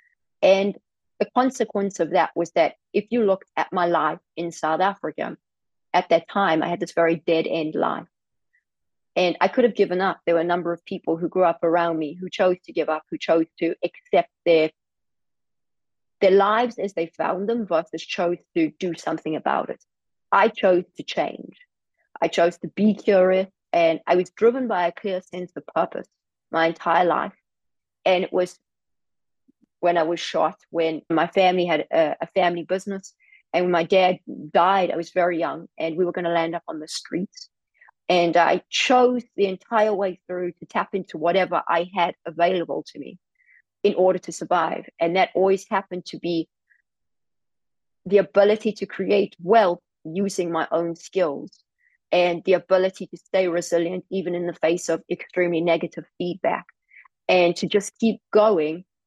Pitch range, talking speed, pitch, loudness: 170-195 Hz, 180 wpm, 180 Hz, -22 LUFS